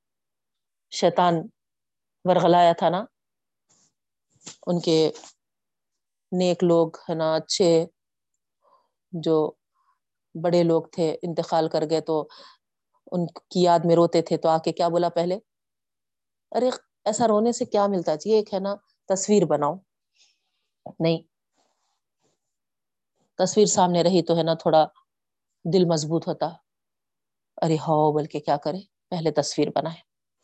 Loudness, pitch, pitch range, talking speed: -23 LUFS, 170 Hz, 160-185 Hz, 125 wpm